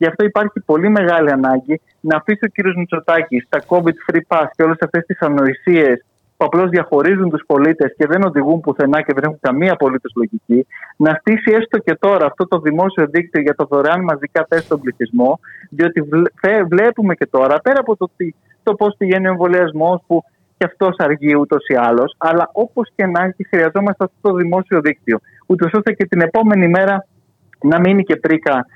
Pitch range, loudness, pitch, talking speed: 150-190 Hz, -15 LUFS, 170 Hz, 185 wpm